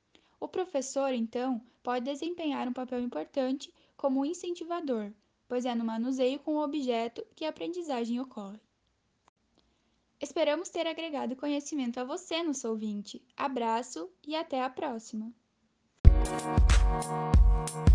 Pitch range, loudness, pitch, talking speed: 225-300 Hz, -32 LUFS, 255 Hz, 115 wpm